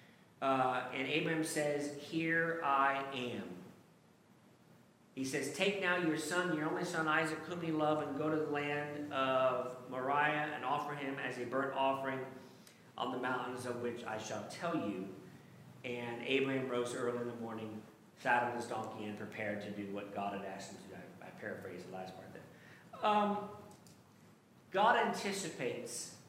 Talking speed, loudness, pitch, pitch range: 170 wpm, -37 LUFS, 135 Hz, 120-155 Hz